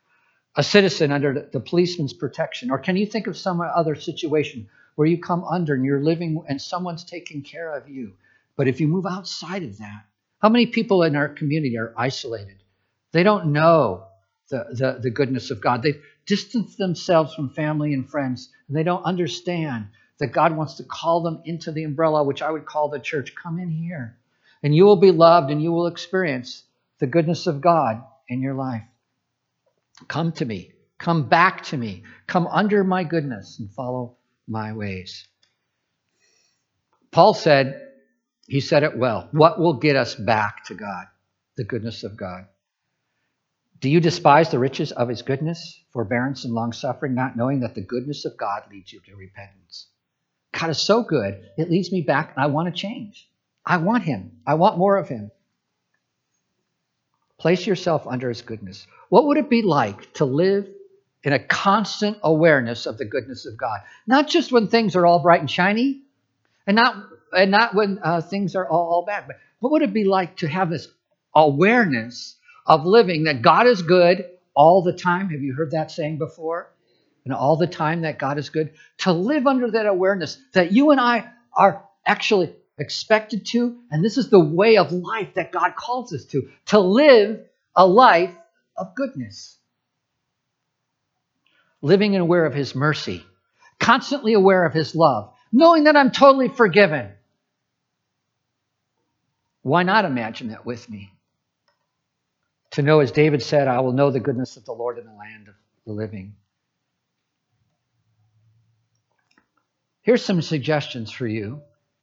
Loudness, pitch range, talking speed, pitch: -20 LUFS, 125-185 Hz, 170 wpm, 155 Hz